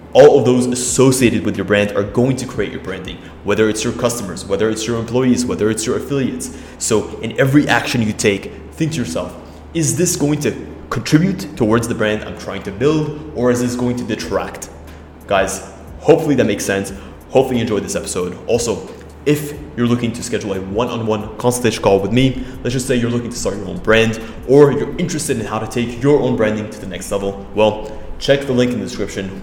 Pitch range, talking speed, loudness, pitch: 100-130 Hz, 220 wpm, -17 LUFS, 115 Hz